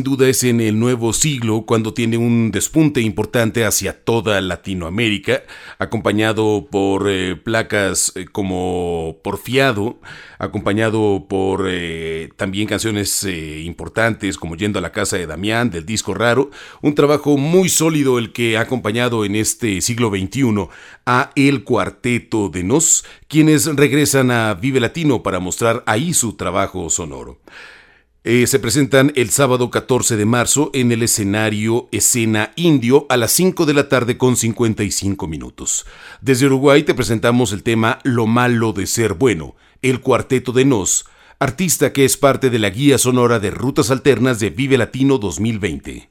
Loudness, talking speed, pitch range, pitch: -16 LUFS, 155 wpm, 100-130 Hz, 115 Hz